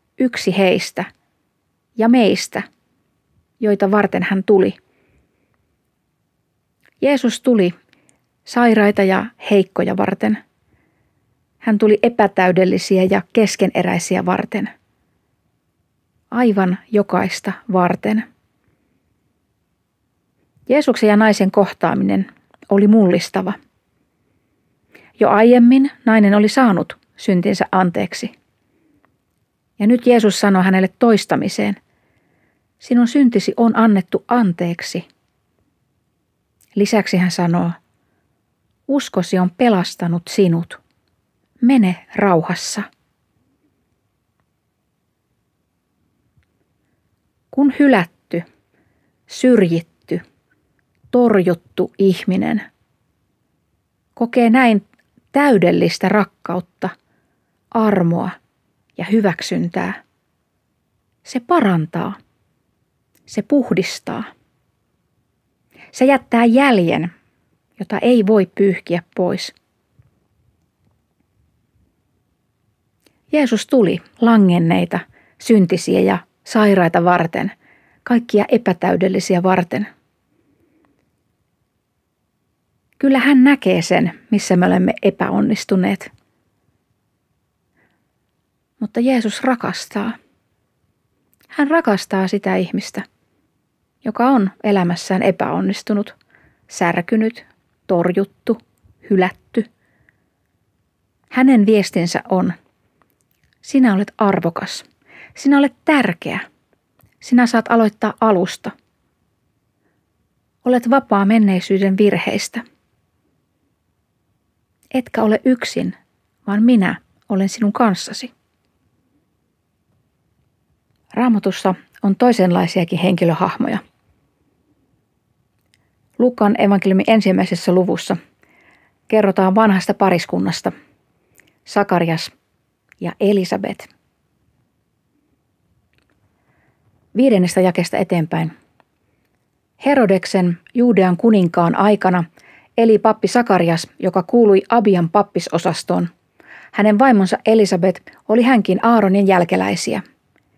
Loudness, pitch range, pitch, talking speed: -16 LUFS, 185-230 Hz, 205 Hz, 70 wpm